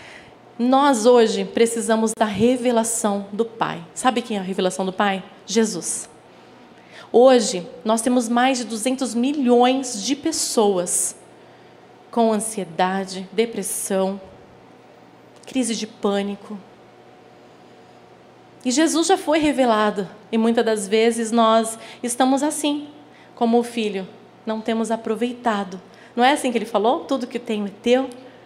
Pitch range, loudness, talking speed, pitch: 210-250 Hz, -20 LUFS, 125 wpm, 230 Hz